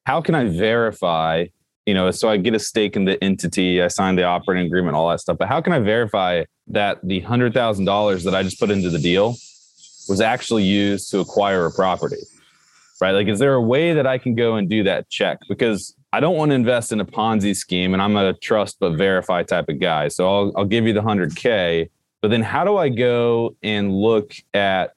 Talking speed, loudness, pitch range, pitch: 225 wpm, -19 LUFS, 95-115 Hz, 100 Hz